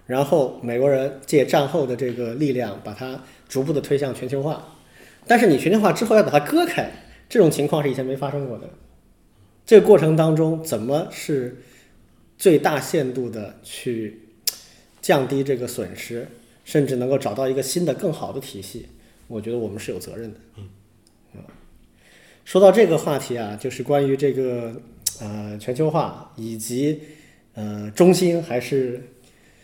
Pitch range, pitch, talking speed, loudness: 115-145 Hz, 130 Hz, 240 characters per minute, -21 LUFS